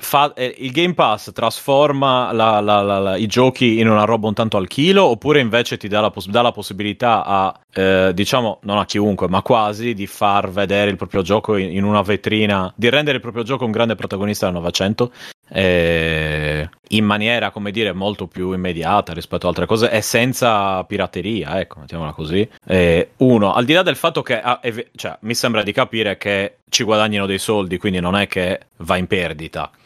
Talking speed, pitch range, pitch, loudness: 200 wpm, 95-120 Hz, 105 Hz, -17 LUFS